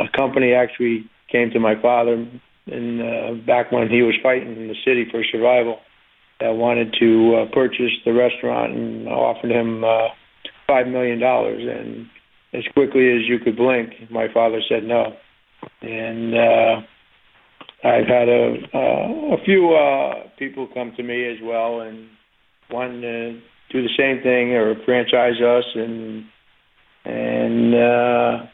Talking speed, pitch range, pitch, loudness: 150 wpm, 115-125 Hz, 120 Hz, -19 LUFS